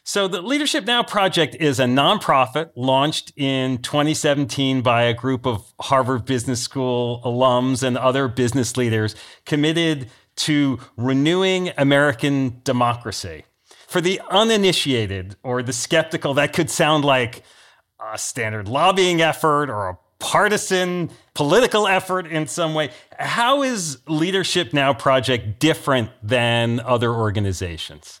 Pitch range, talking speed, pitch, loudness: 125-160 Hz, 125 wpm, 135 Hz, -19 LUFS